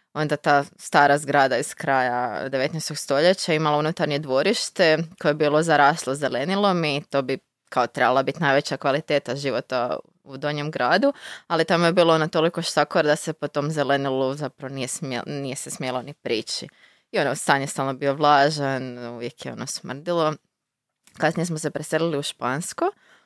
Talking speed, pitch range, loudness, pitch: 170 wpm, 135-160 Hz, -23 LUFS, 145 Hz